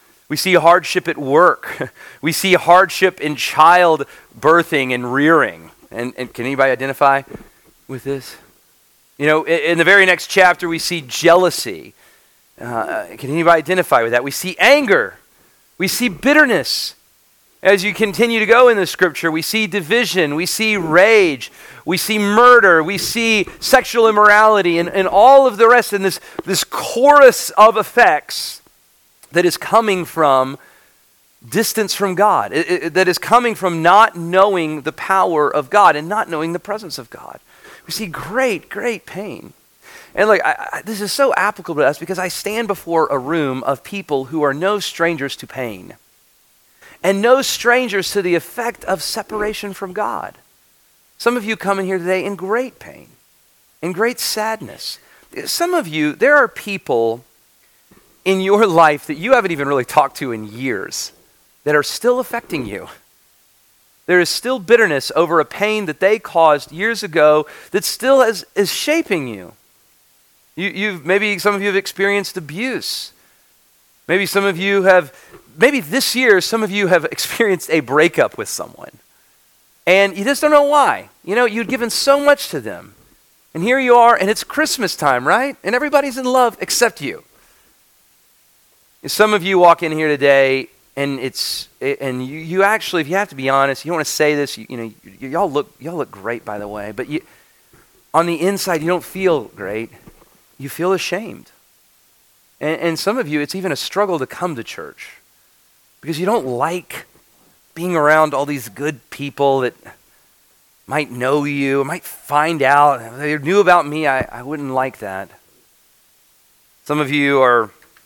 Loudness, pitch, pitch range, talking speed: -15 LUFS, 180 Hz, 150-210 Hz, 175 wpm